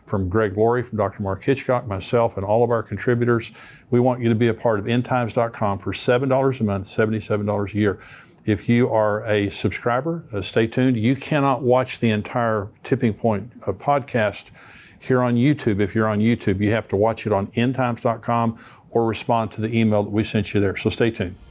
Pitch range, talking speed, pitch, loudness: 105-125 Hz, 210 wpm, 115 Hz, -21 LUFS